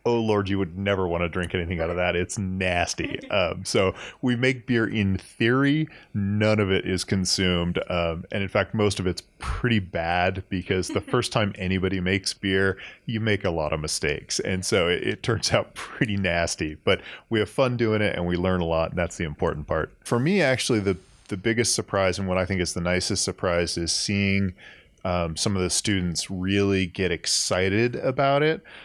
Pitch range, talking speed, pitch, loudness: 90-105 Hz, 205 wpm, 95 Hz, -24 LUFS